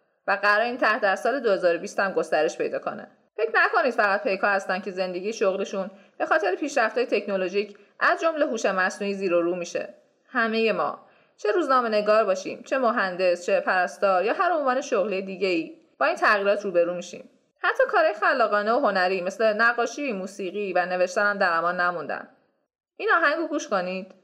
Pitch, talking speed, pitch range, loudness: 205 Hz, 175 wpm, 190-285 Hz, -24 LUFS